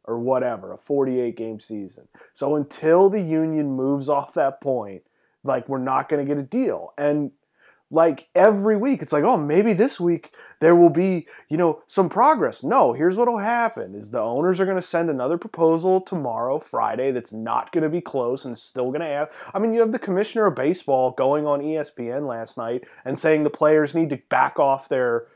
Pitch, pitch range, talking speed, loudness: 155 Hz, 135-185 Hz, 200 wpm, -21 LUFS